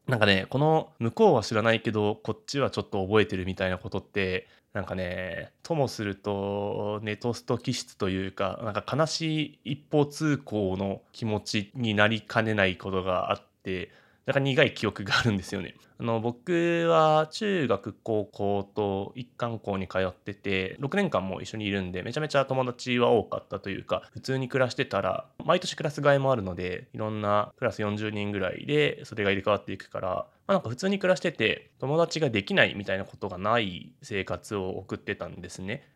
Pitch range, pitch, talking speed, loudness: 100-135 Hz, 110 Hz, 380 characters per minute, -28 LUFS